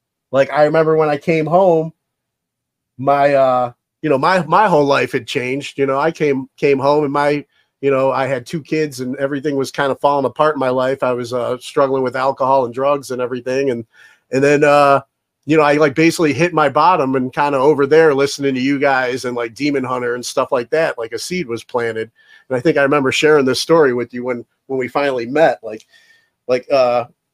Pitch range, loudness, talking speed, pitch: 130-150 Hz, -16 LUFS, 225 wpm, 140 Hz